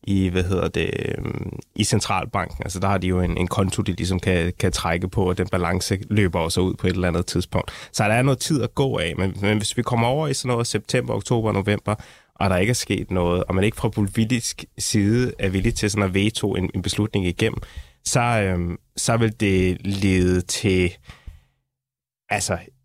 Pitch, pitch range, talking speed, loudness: 100 Hz, 90-115 Hz, 215 wpm, -22 LUFS